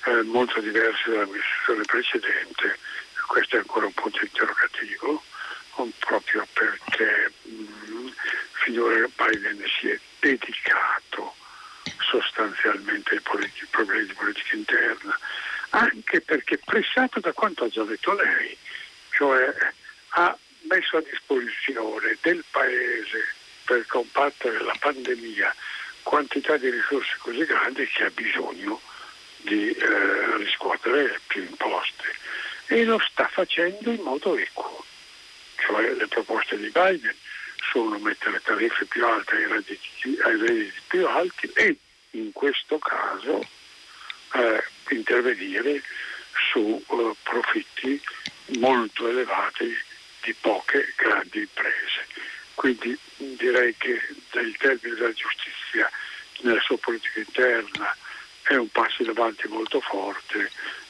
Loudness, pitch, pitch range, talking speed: -24 LUFS, 365 Hz, 315-425 Hz, 110 wpm